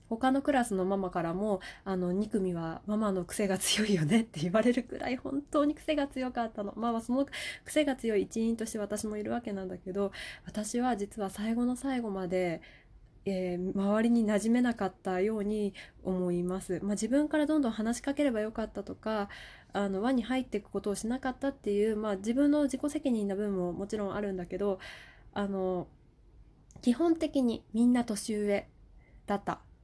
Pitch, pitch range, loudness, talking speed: 215 Hz, 195-245 Hz, -32 LUFS, 360 characters per minute